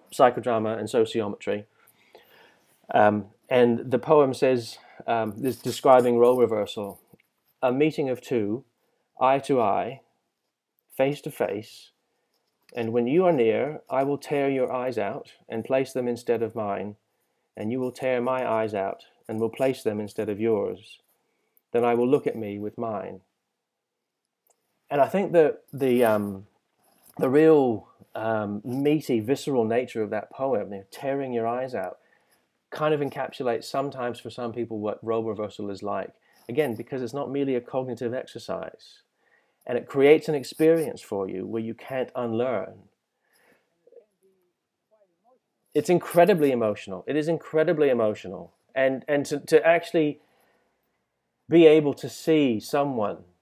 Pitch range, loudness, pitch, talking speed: 115-145 Hz, -25 LUFS, 125 Hz, 150 wpm